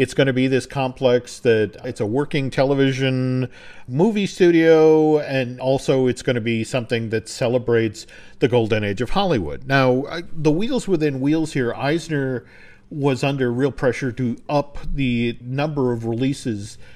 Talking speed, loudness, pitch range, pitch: 155 wpm, -20 LUFS, 125-145 Hz, 130 Hz